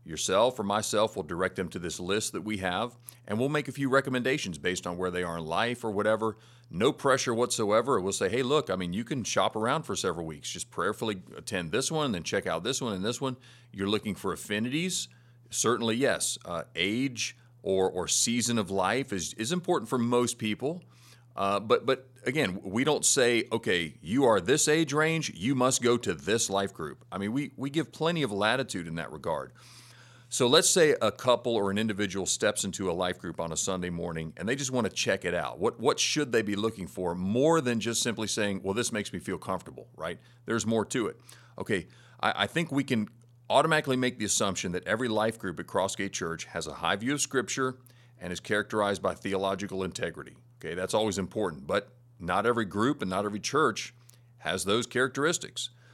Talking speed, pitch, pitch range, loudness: 215 wpm, 115 Hz, 100-125 Hz, -29 LUFS